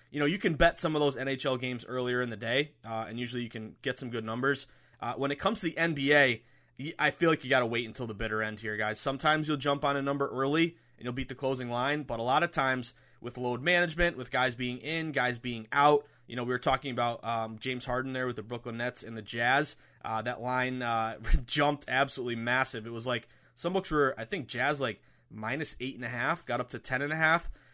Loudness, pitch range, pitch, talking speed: -31 LUFS, 120-145 Hz, 130 Hz, 255 wpm